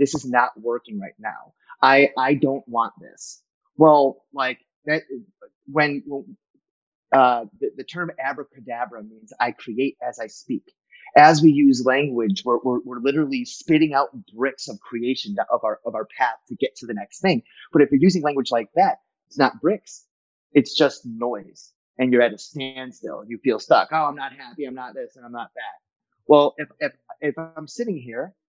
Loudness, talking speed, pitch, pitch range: -21 LUFS, 190 wpm, 140 Hz, 125-155 Hz